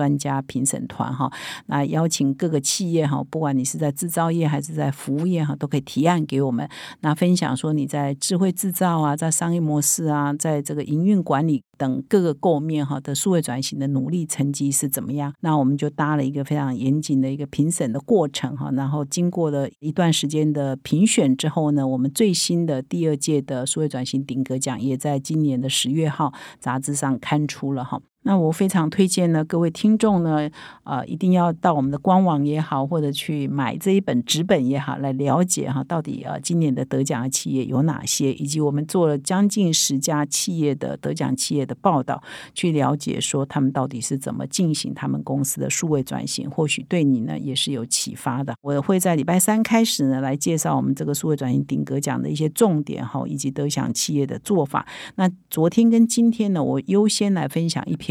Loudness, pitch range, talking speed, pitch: -22 LUFS, 135-165 Hz, 315 characters per minute, 150 Hz